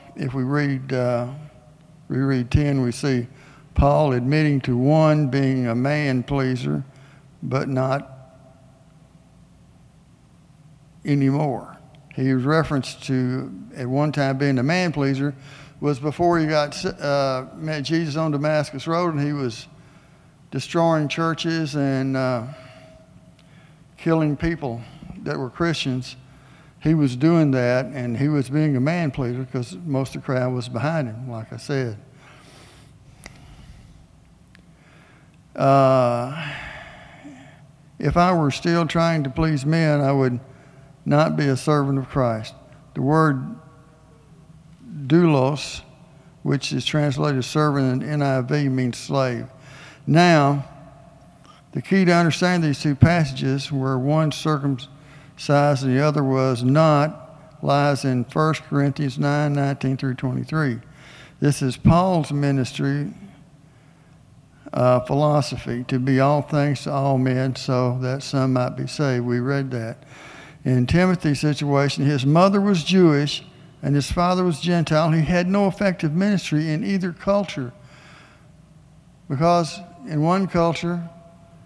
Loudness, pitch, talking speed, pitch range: -21 LUFS, 145 Hz, 130 wpm, 135-155 Hz